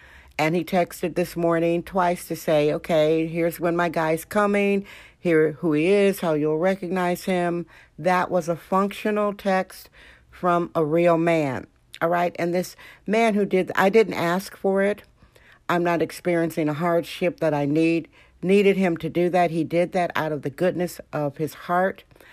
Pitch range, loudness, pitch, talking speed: 160-185 Hz, -23 LUFS, 175 Hz, 175 wpm